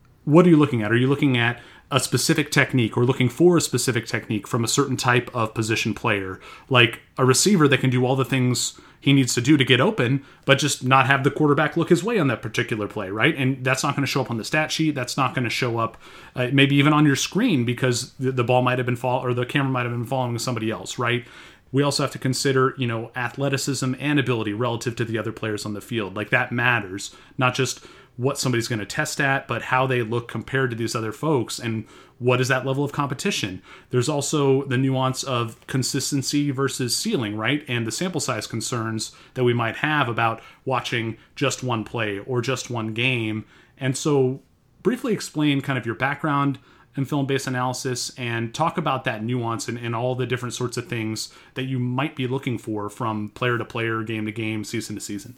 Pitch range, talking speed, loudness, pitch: 115-140 Hz, 230 wpm, -22 LUFS, 125 Hz